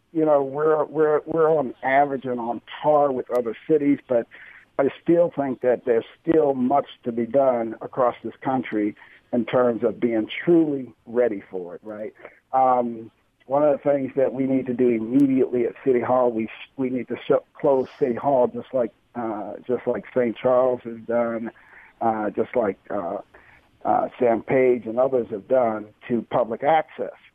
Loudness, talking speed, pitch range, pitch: -23 LUFS, 180 wpm, 120-140 Hz, 125 Hz